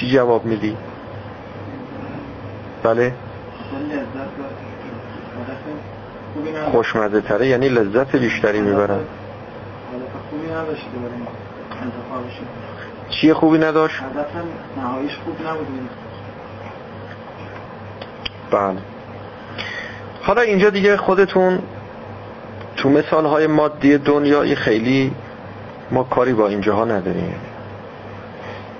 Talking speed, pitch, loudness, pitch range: 65 wpm, 125 Hz, -19 LUFS, 110-150 Hz